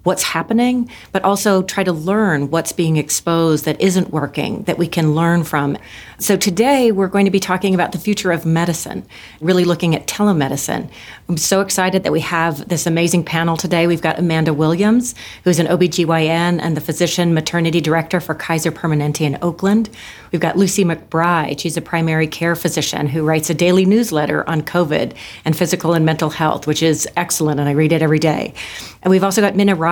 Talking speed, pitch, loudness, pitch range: 195 wpm, 170 Hz, -16 LUFS, 160-185 Hz